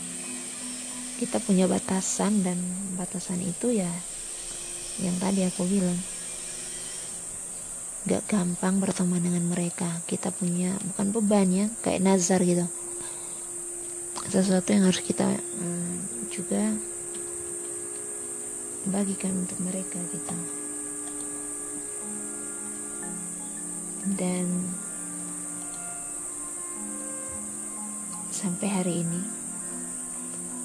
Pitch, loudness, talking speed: 180 Hz, -28 LUFS, 75 wpm